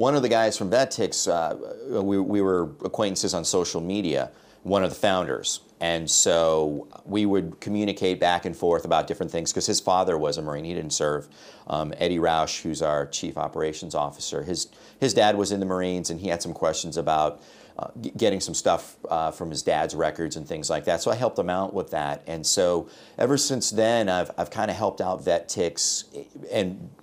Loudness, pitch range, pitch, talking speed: -25 LUFS, 80-100 Hz, 85 Hz, 205 wpm